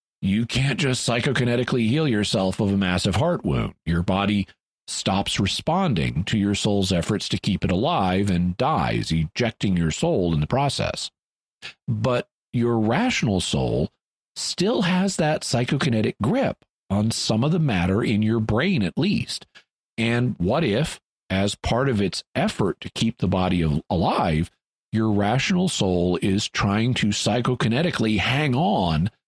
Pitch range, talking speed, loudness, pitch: 95-125 Hz, 150 wpm, -23 LUFS, 105 Hz